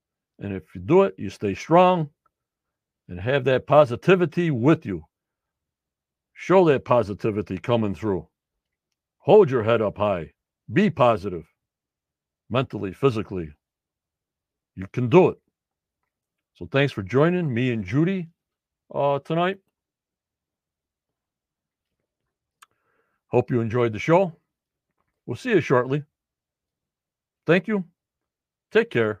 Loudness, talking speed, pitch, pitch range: -22 LUFS, 110 wpm, 125 Hz, 100-160 Hz